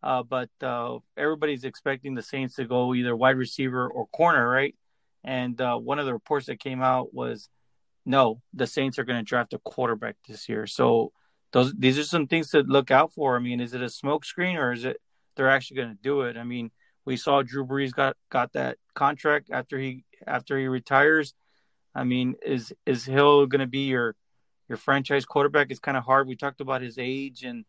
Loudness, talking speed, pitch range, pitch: -25 LUFS, 210 wpm, 125-140 Hz, 130 Hz